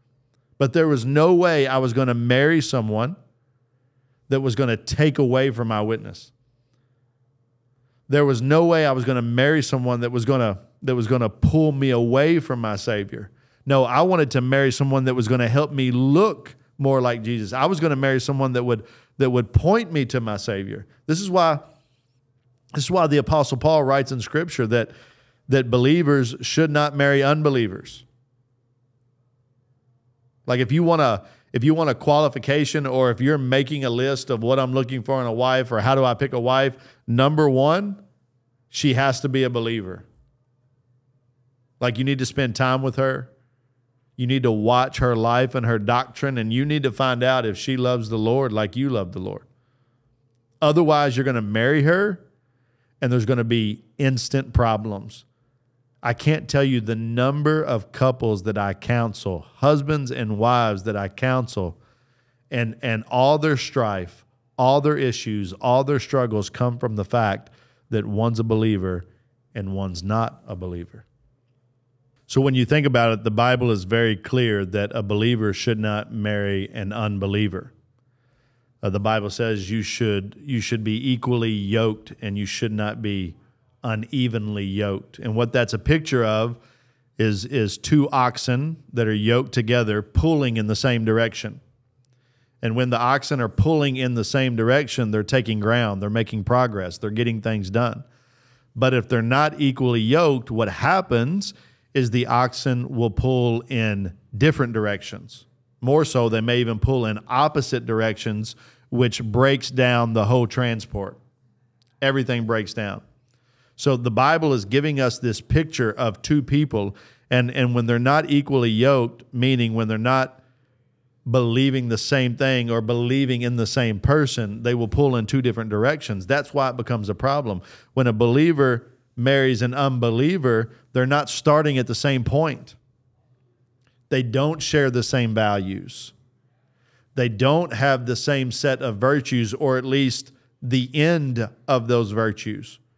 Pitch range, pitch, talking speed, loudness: 115-135 Hz, 125 Hz, 170 wpm, -21 LUFS